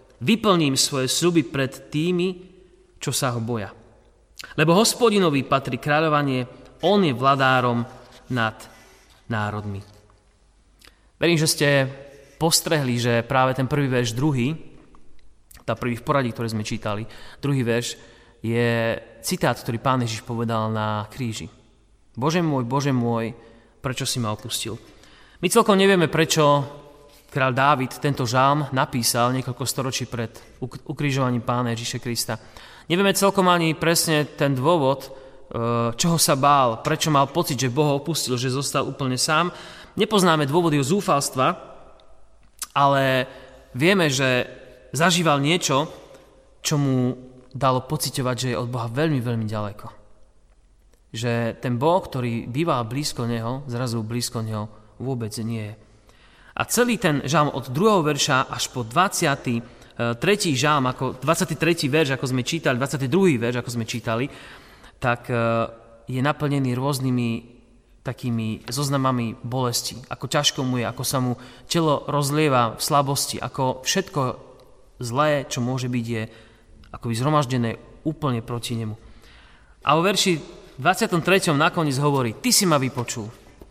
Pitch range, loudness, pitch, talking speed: 120-150 Hz, -22 LUFS, 130 Hz, 130 wpm